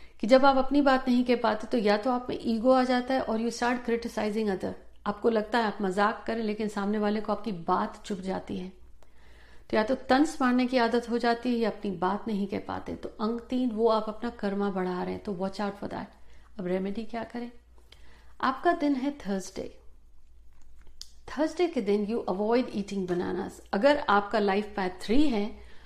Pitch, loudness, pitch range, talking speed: 220 Hz, -28 LUFS, 200-245 Hz, 210 wpm